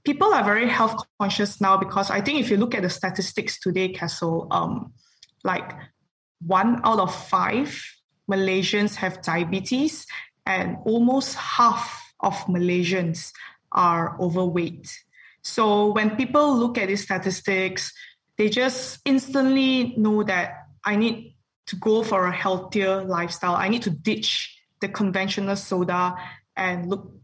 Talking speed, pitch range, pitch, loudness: 135 wpm, 185-225 Hz, 195 Hz, -23 LUFS